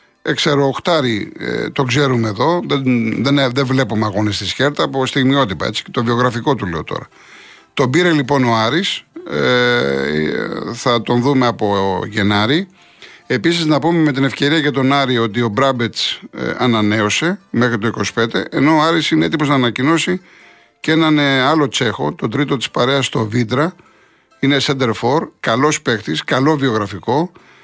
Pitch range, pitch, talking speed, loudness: 115-150 Hz, 135 Hz, 160 wpm, -16 LUFS